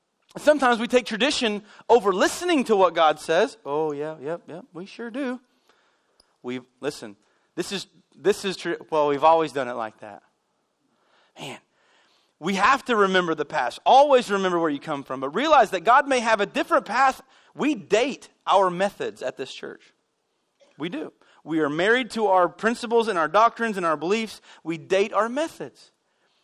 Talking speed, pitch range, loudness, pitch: 180 wpm, 160-240 Hz, -22 LUFS, 200 Hz